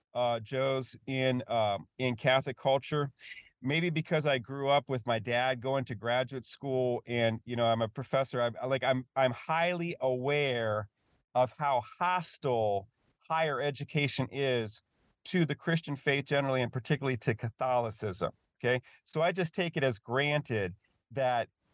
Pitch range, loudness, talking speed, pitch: 120-145 Hz, -32 LUFS, 150 wpm, 130 Hz